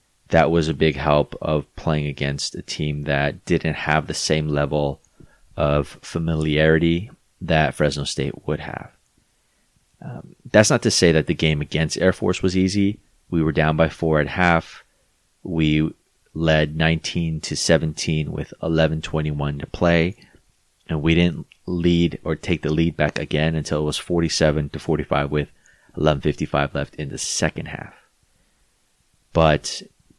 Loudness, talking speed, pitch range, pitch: -21 LUFS, 155 wpm, 75-85 Hz, 80 Hz